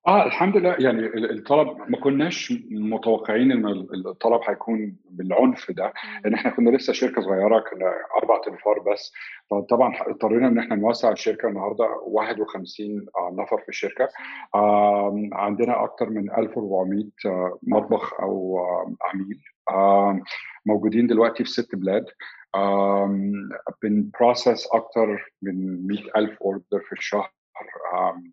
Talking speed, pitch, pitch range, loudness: 125 wpm, 105 Hz, 100-115 Hz, -23 LUFS